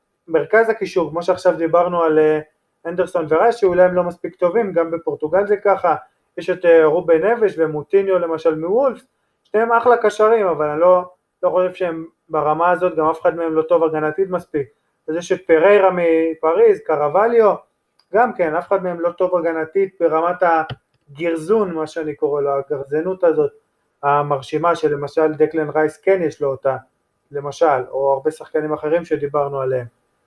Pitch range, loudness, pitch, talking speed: 155-185 Hz, -18 LUFS, 170 Hz, 155 wpm